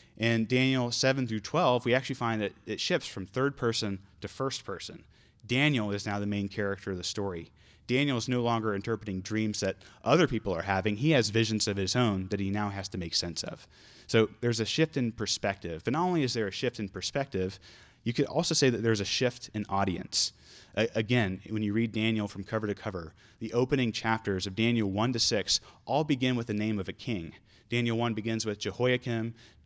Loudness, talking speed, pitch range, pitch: -30 LUFS, 215 wpm, 100-120 Hz, 110 Hz